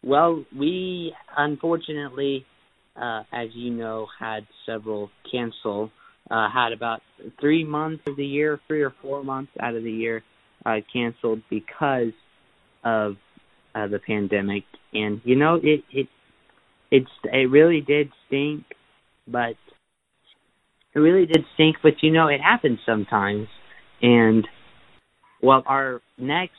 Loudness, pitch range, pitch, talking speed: -23 LUFS, 110-150 Hz, 130 Hz, 130 wpm